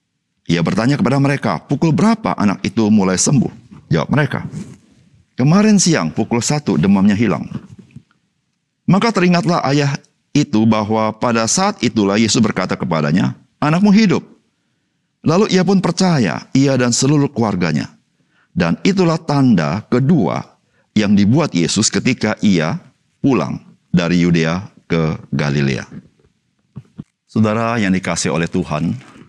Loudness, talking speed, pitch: -15 LUFS, 120 wpm, 135 Hz